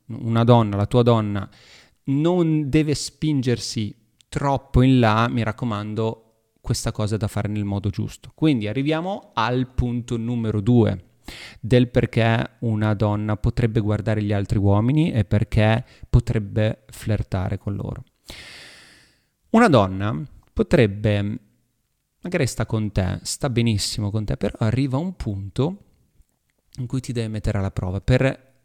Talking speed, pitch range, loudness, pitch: 140 wpm, 105-125 Hz, -22 LUFS, 115 Hz